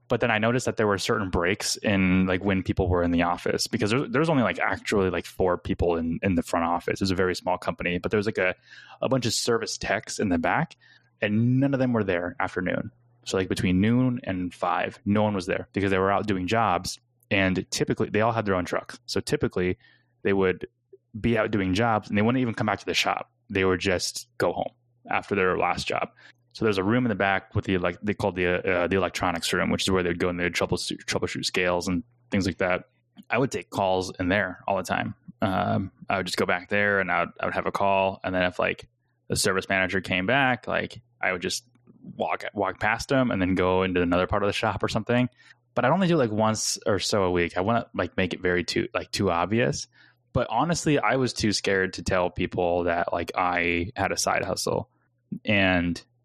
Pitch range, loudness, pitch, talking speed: 90-115 Hz, -25 LUFS, 100 Hz, 245 wpm